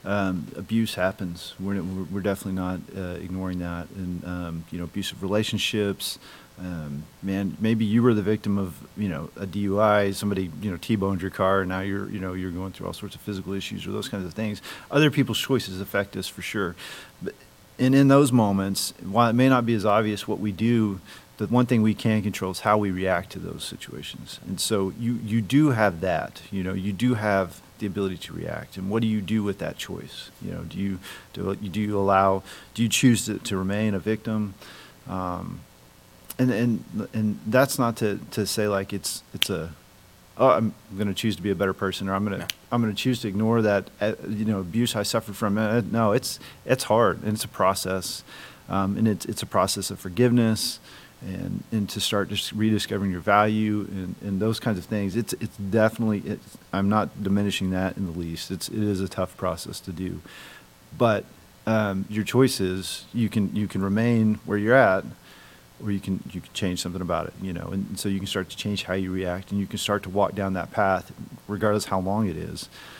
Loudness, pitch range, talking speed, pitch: -25 LUFS, 95-110 Hz, 215 wpm, 100 Hz